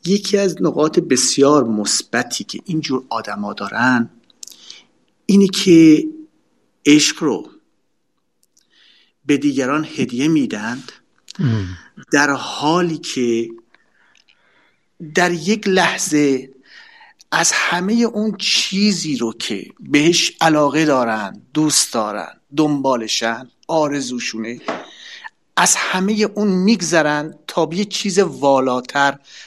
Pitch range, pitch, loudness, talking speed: 130-200 Hz, 155 Hz, -17 LUFS, 90 wpm